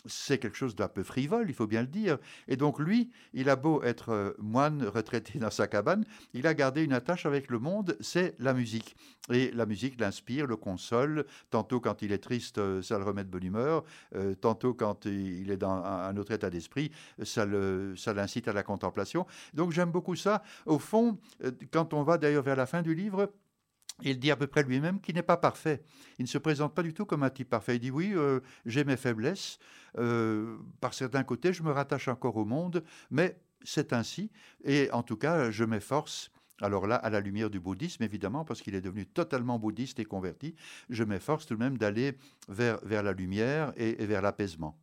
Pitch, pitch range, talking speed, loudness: 125 Hz, 110-155 Hz, 215 wpm, -32 LUFS